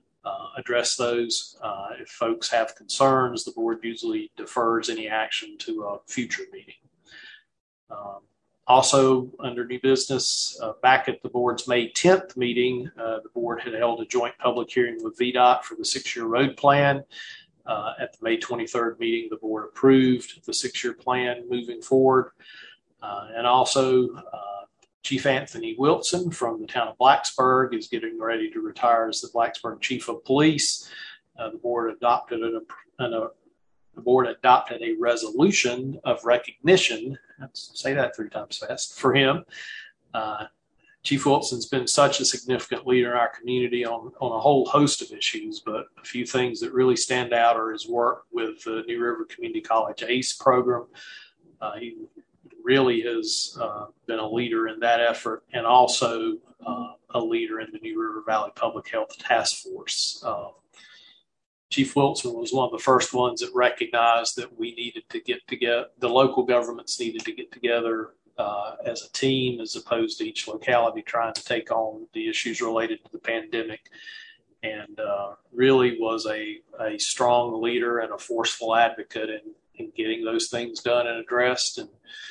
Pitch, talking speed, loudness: 125 Hz, 170 wpm, -24 LUFS